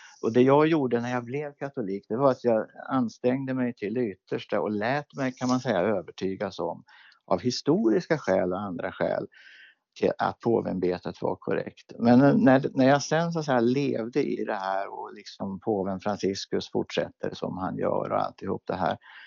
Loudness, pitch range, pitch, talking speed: -27 LUFS, 105-140 Hz, 125 Hz, 180 wpm